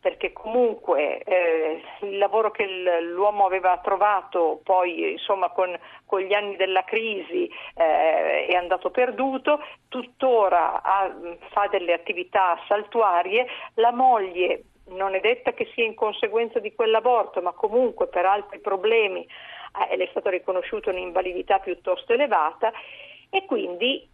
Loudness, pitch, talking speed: -23 LUFS, 205 Hz, 130 wpm